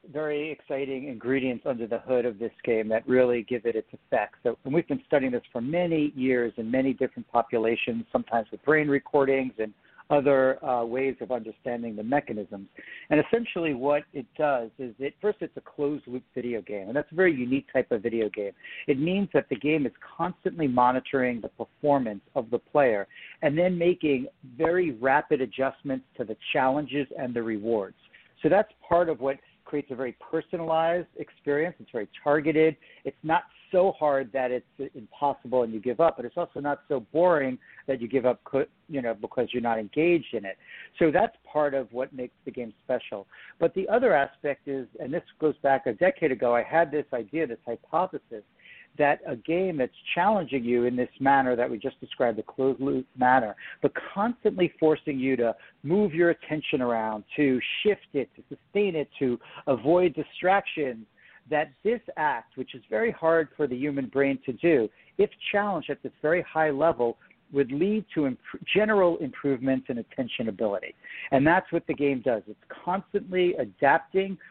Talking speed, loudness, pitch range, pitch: 185 wpm, -27 LUFS, 125-165 Hz, 140 Hz